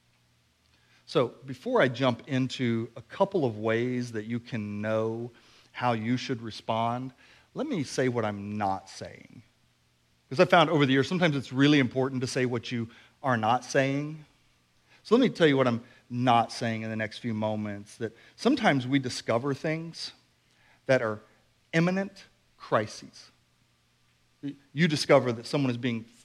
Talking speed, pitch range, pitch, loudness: 160 wpm, 110-135 Hz, 120 Hz, -28 LUFS